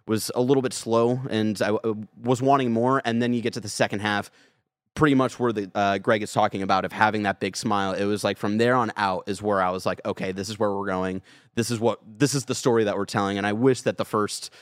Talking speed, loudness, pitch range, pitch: 270 wpm, -24 LUFS, 100-120 Hz, 110 Hz